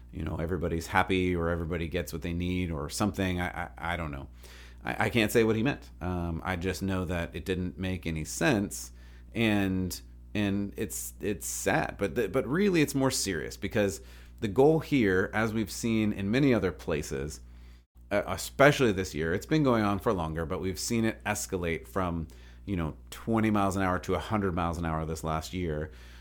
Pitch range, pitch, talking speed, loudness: 80-100 Hz, 90 Hz, 195 wpm, -30 LUFS